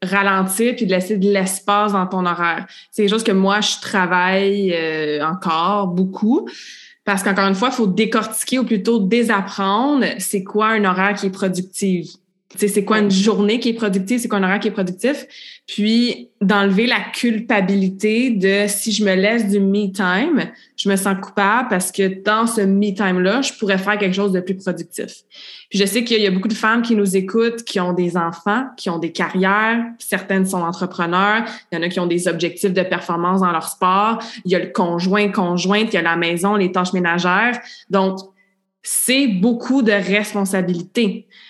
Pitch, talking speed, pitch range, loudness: 200 Hz, 195 wpm, 185-220 Hz, -18 LUFS